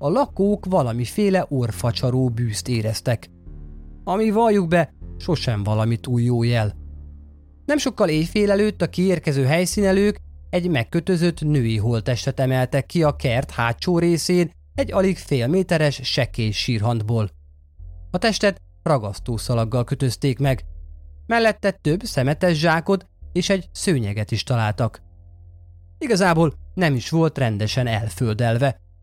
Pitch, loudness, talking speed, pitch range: 130 Hz, -21 LUFS, 120 wpm, 105-175 Hz